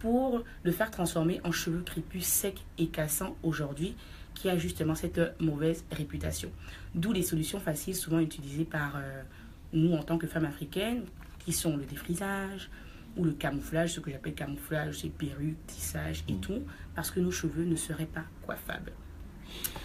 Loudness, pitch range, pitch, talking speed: -33 LUFS, 145-175 Hz, 160 Hz, 165 wpm